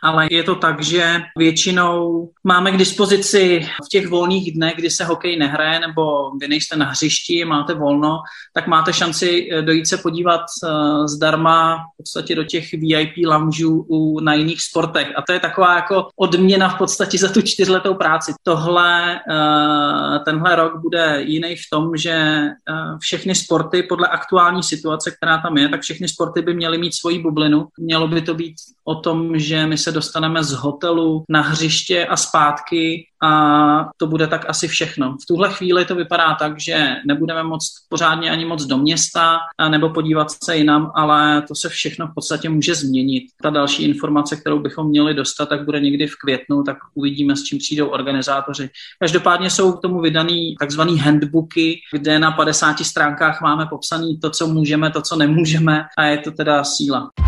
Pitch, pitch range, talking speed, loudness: 160 Hz, 150-170 Hz, 175 wpm, -17 LUFS